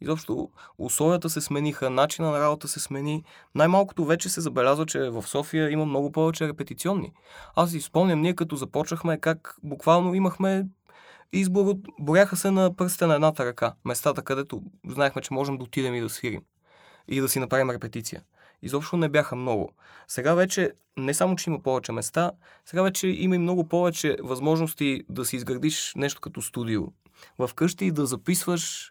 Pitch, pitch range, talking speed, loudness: 155 Hz, 135-175 Hz, 165 wpm, -26 LUFS